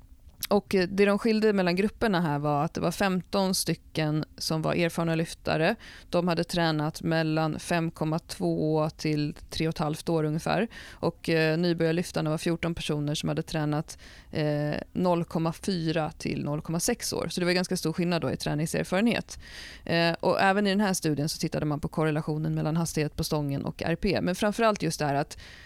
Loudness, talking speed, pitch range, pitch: -28 LUFS, 160 wpm, 155-180 Hz, 165 Hz